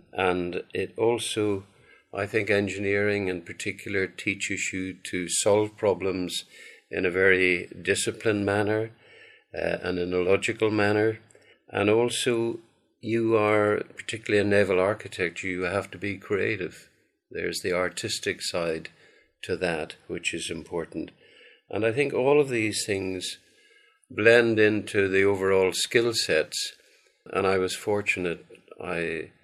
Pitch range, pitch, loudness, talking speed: 95-115 Hz, 105 Hz, -26 LUFS, 130 wpm